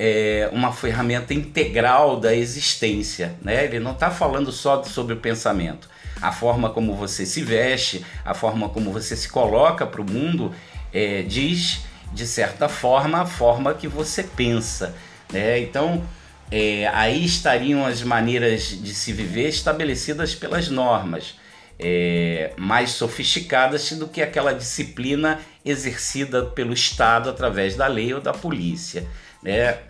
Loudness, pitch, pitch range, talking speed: -21 LUFS, 120 Hz, 105-140 Hz, 140 wpm